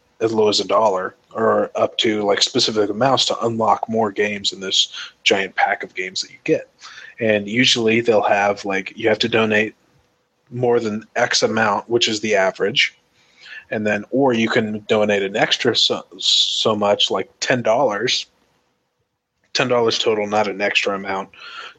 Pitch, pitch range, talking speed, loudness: 110 Hz, 105-115 Hz, 165 wpm, -18 LUFS